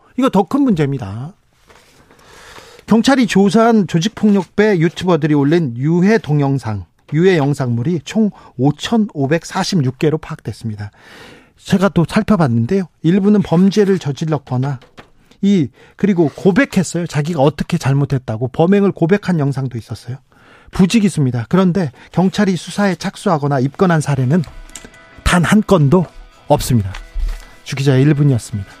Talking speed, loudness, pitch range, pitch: 300 characters per minute, -15 LUFS, 135-195 Hz, 165 Hz